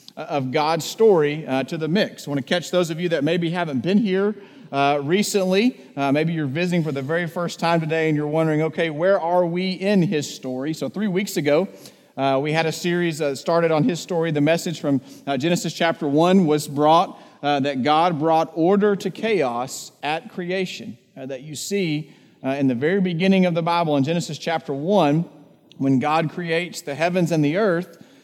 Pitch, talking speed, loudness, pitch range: 165 Hz, 210 wpm, -21 LUFS, 145-180 Hz